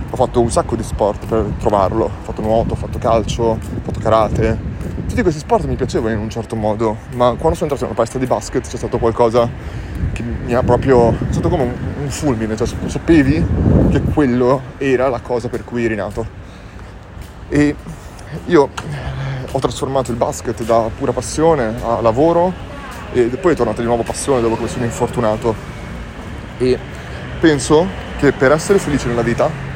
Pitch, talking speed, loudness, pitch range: 120 Hz, 180 wpm, -17 LUFS, 110-130 Hz